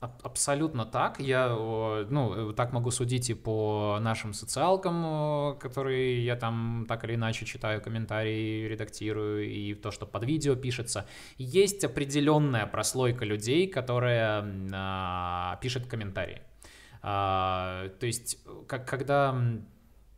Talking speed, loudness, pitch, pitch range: 115 wpm, -30 LUFS, 115 Hz, 105-130 Hz